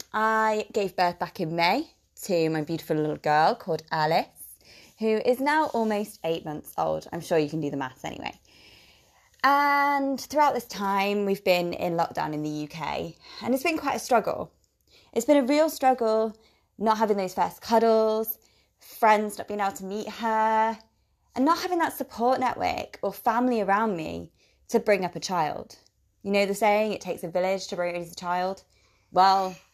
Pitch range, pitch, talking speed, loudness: 170-230 Hz, 205 Hz, 180 wpm, -26 LUFS